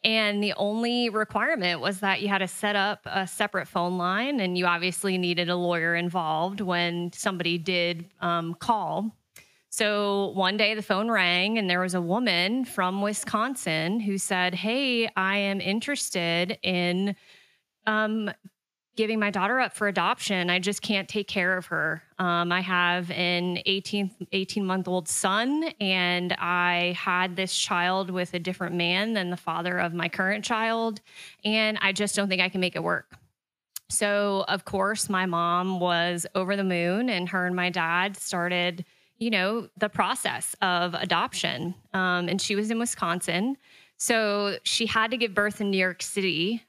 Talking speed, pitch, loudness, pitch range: 170 wpm, 190 Hz, -26 LUFS, 180-210 Hz